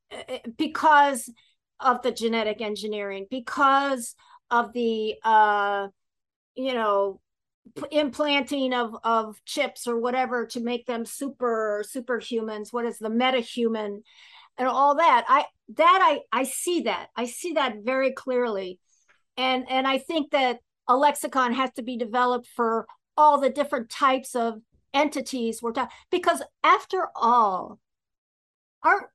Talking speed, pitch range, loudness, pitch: 135 wpm, 230-280 Hz, -24 LUFS, 250 Hz